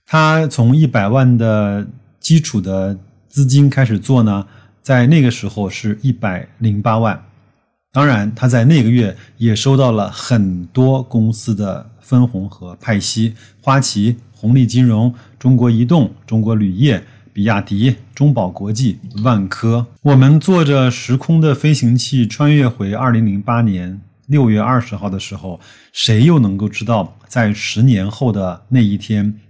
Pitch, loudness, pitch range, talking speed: 115 Hz, -14 LUFS, 105-130 Hz, 225 characters per minute